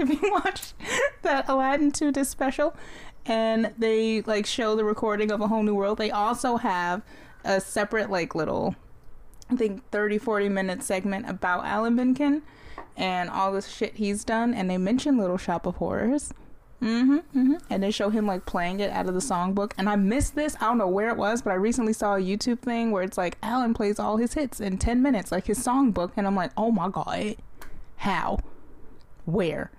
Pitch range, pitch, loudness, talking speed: 195-245 Hz, 215 Hz, -26 LUFS, 200 wpm